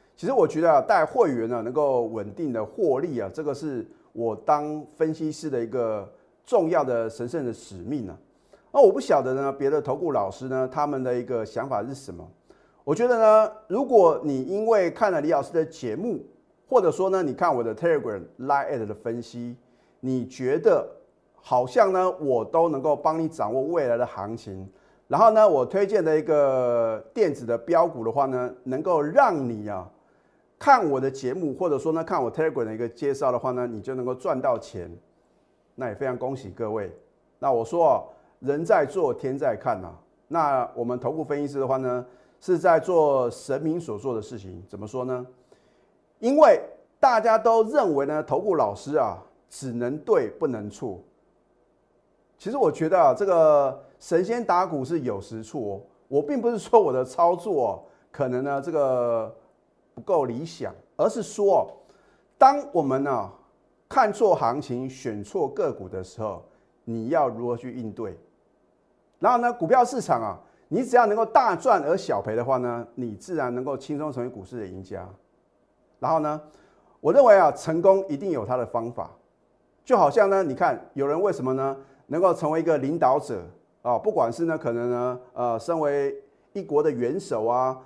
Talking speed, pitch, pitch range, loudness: 270 characters per minute, 135 Hz, 120-165 Hz, -24 LUFS